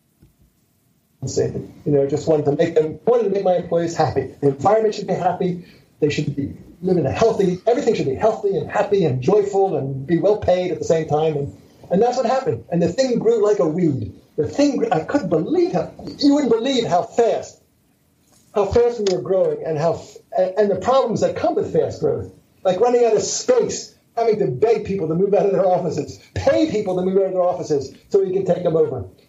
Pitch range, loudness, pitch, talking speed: 165-230 Hz, -19 LUFS, 190 Hz, 225 wpm